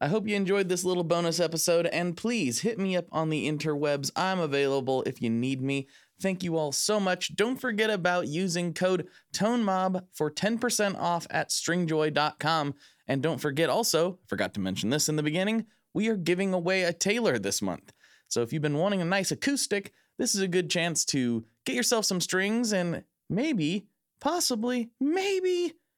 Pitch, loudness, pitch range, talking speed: 180 Hz, -28 LUFS, 155-205 Hz, 180 wpm